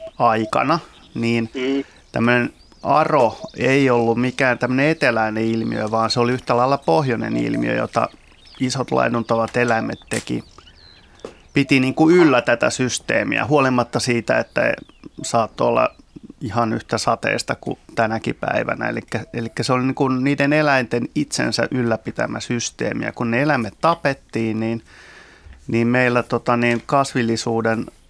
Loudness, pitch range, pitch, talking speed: -19 LUFS, 115-135 Hz, 120 Hz, 130 wpm